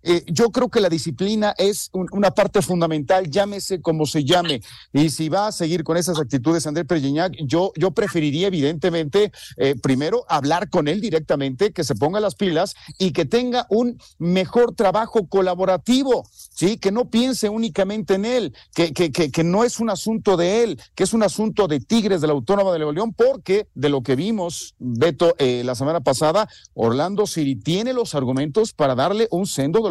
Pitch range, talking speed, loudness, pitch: 155-210 Hz, 190 wpm, -20 LUFS, 180 Hz